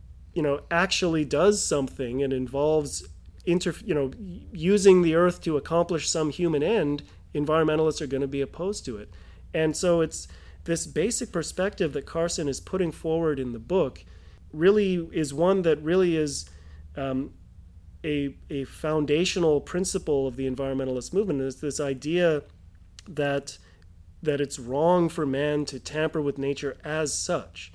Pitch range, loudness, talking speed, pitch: 130-170 Hz, -26 LUFS, 150 wpm, 150 Hz